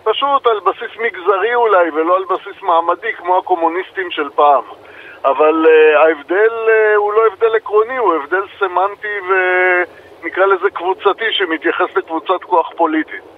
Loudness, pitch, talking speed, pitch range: -14 LUFS, 190 Hz, 145 wpm, 175-225 Hz